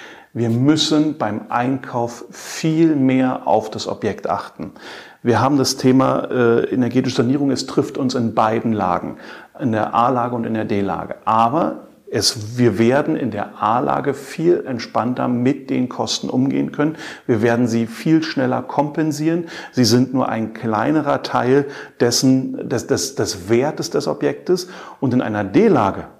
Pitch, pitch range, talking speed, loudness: 125 Hz, 115-140 Hz, 145 wpm, -18 LUFS